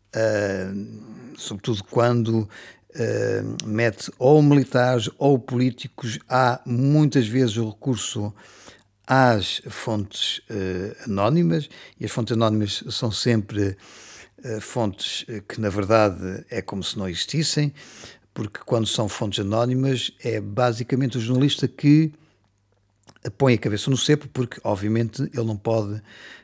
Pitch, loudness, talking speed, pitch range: 115 Hz, -23 LUFS, 125 wpm, 105-130 Hz